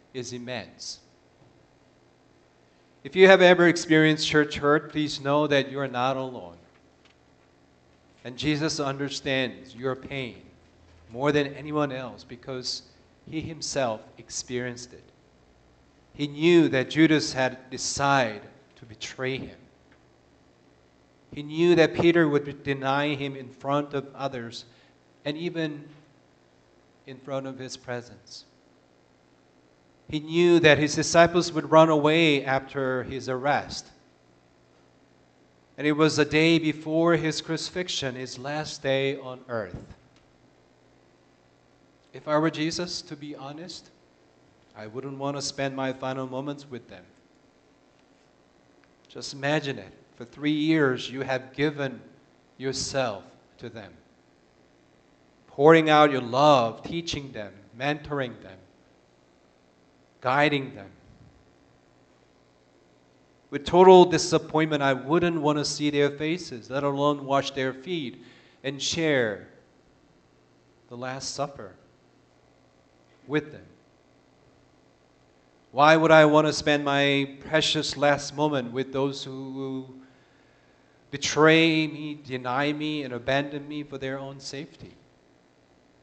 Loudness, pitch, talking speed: -24 LUFS, 130 Hz, 115 wpm